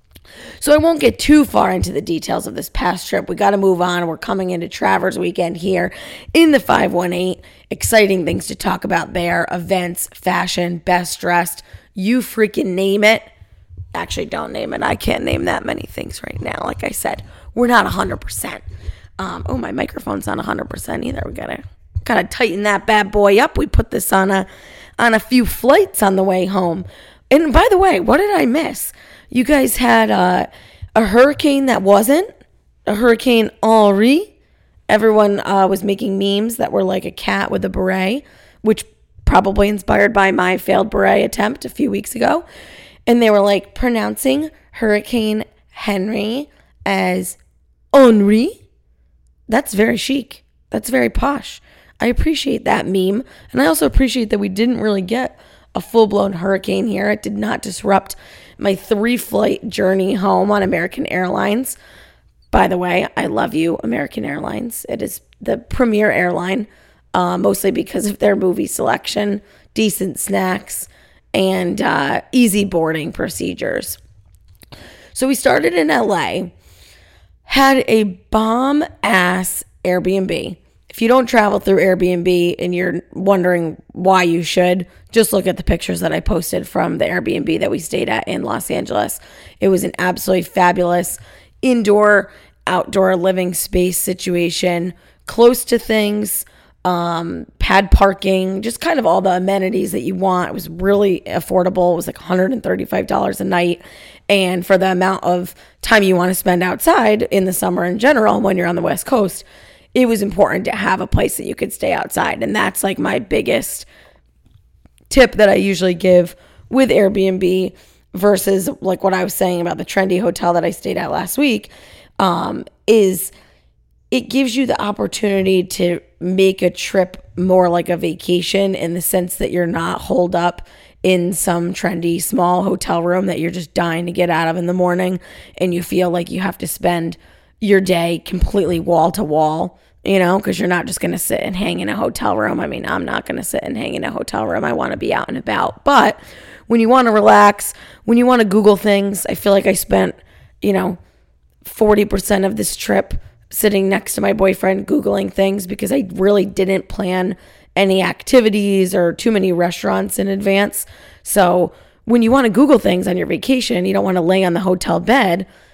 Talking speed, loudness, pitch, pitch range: 180 wpm, -16 LUFS, 190 Hz, 180-220 Hz